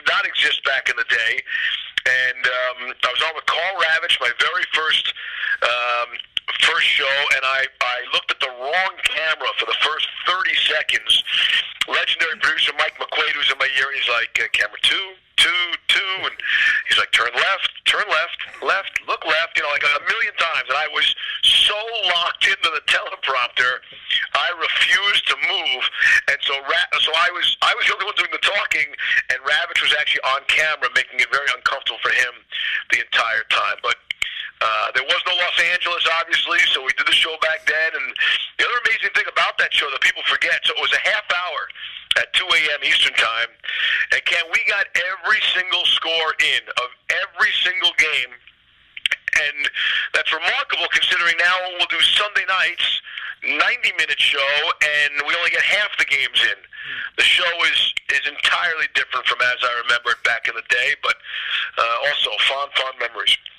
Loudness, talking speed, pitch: -18 LUFS, 180 wpm, 190 Hz